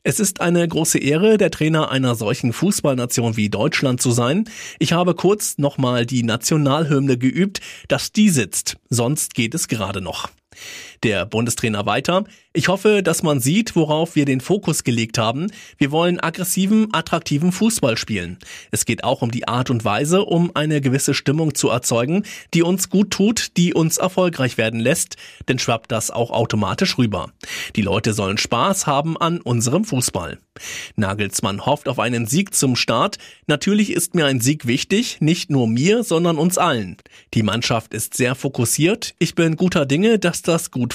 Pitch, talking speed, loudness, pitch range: 145 Hz, 170 wpm, -19 LUFS, 120-175 Hz